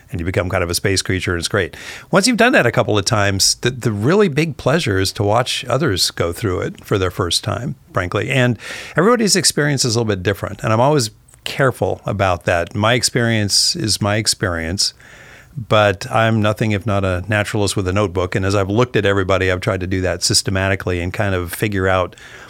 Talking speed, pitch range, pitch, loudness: 220 wpm, 95-120 Hz, 105 Hz, -17 LUFS